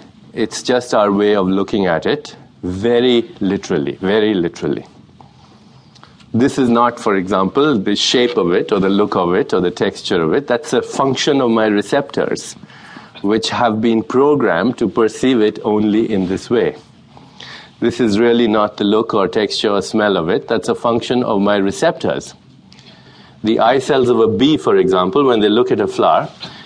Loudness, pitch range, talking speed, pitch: -15 LUFS, 105-125 Hz, 180 wpm, 115 Hz